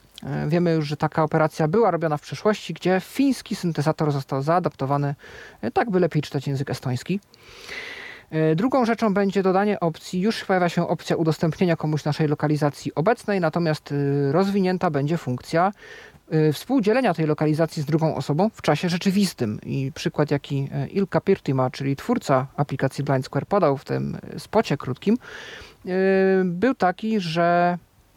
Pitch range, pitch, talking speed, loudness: 145-190 Hz, 165 Hz, 140 wpm, -23 LUFS